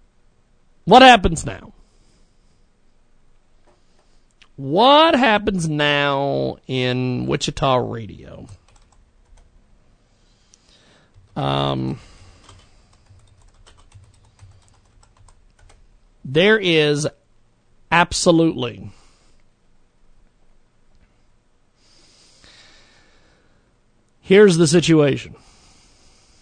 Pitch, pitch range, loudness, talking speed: 110 Hz, 95-145 Hz, -16 LUFS, 35 wpm